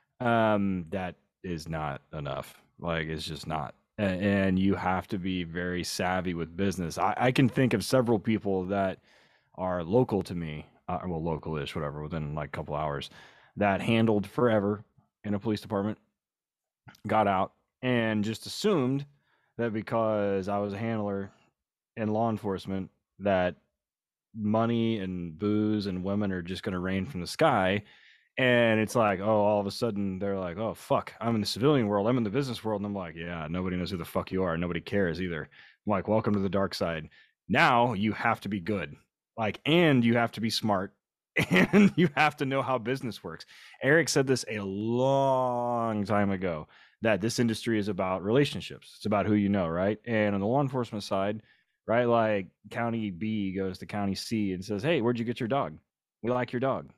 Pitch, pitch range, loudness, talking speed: 105 Hz, 95-115 Hz, -29 LUFS, 195 wpm